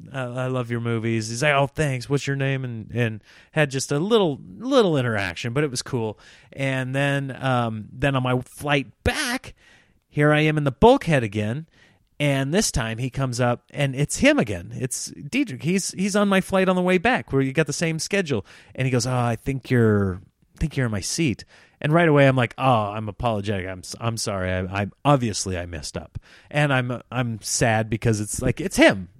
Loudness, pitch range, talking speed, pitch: -23 LUFS, 115-150 Hz, 215 wpm, 130 Hz